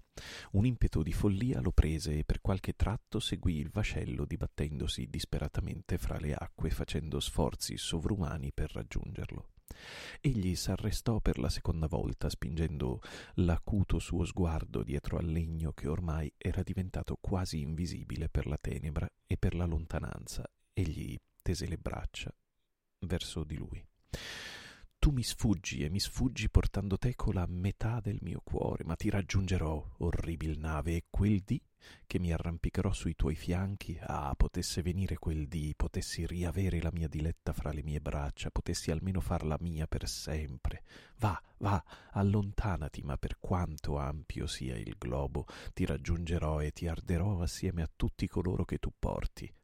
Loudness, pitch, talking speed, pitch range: -36 LUFS, 85 Hz, 150 wpm, 75-95 Hz